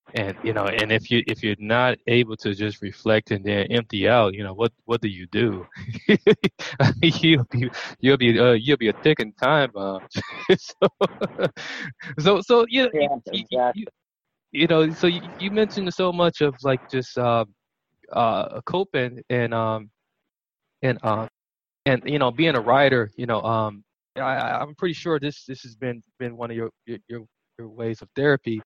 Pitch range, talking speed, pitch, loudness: 110-150 Hz, 185 wpm, 125 Hz, -22 LUFS